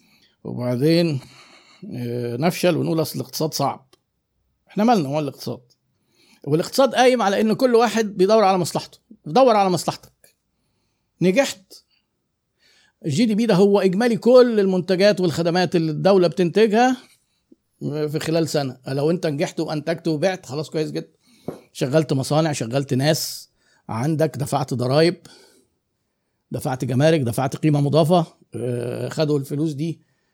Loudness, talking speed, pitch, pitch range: -20 LUFS, 120 wpm, 165 Hz, 145-190 Hz